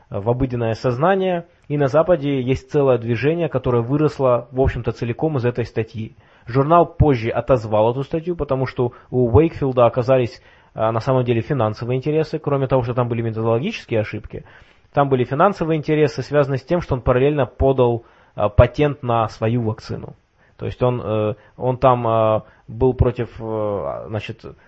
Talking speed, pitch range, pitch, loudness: 150 wpm, 115-140 Hz, 125 Hz, -19 LUFS